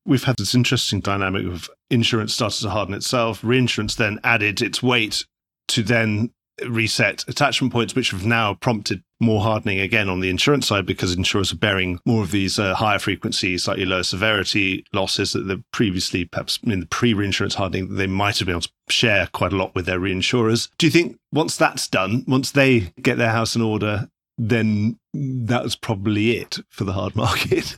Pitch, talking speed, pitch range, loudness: 110 Hz, 190 wpm, 95-120 Hz, -20 LUFS